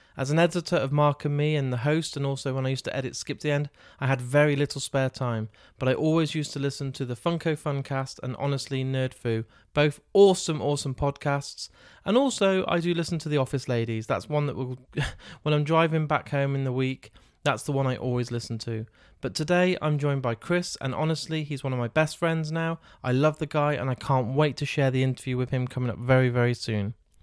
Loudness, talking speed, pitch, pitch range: -27 LUFS, 230 wpm, 140 Hz, 130-155 Hz